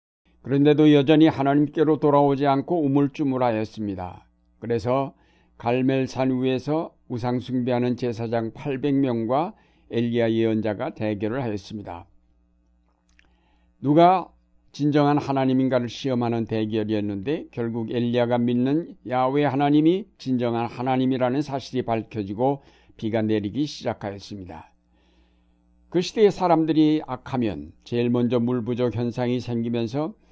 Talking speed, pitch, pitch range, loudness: 295 characters per minute, 125 Hz, 110-140 Hz, -23 LUFS